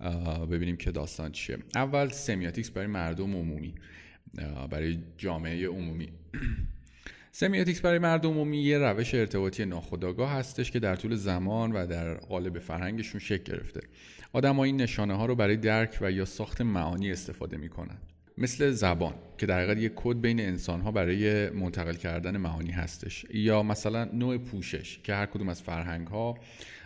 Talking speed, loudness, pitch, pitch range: 160 wpm, -31 LUFS, 95 Hz, 85-115 Hz